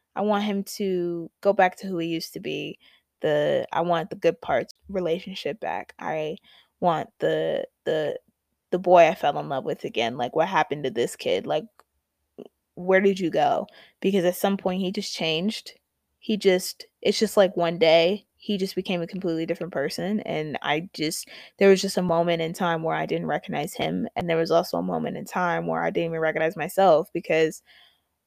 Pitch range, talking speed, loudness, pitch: 165-205 Hz, 200 wpm, -25 LUFS, 185 Hz